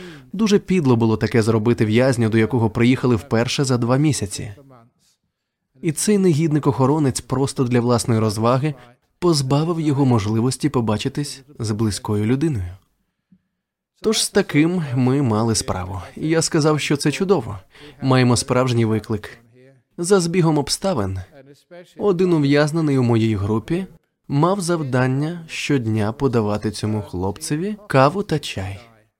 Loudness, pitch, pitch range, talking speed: -19 LUFS, 130 Hz, 115-155 Hz, 120 wpm